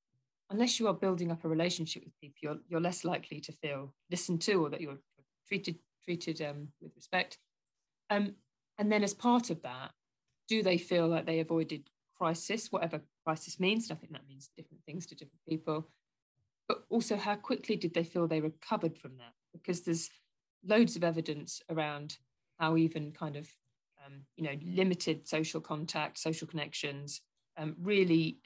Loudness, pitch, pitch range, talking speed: -34 LUFS, 165 Hz, 150-180 Hz, 175 wpm